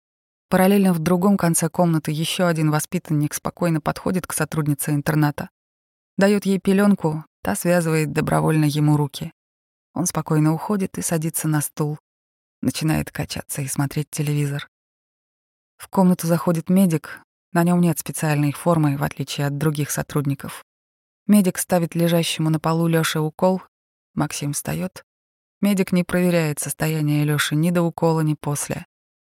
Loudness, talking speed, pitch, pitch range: -21 LUFS, 135 wpm, 160 Hz, 150-175 Hz